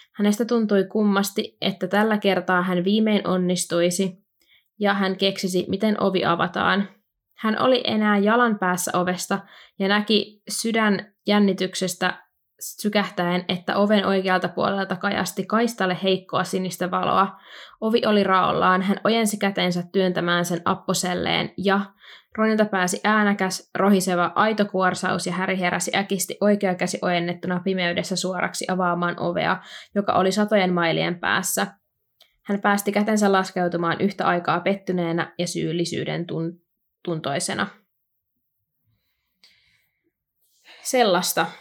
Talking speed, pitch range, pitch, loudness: 110 wpm, 180-205 Hz, 190 Hz, -22 LUFS